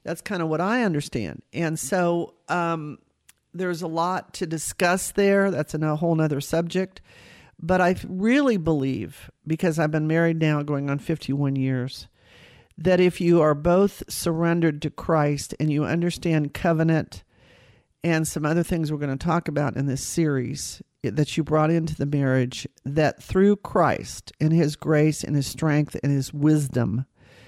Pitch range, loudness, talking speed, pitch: 145-170 Hz, -24 LUFS, 165 wpm, 160 Hz